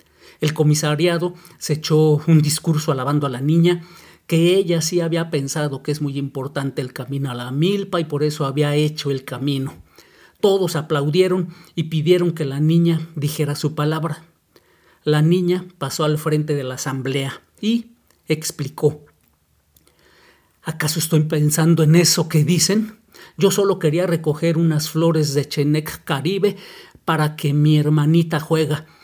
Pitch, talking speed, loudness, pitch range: 155 Hz, 150 wpm, -19 LUFS, 145-170 Hz